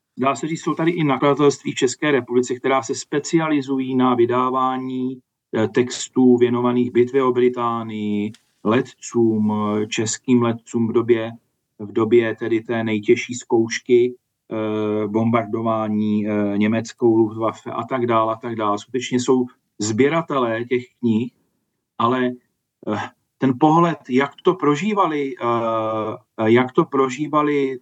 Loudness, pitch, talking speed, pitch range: -20 LUFS, 120 Hz, 125 wpm, 115-130 Hz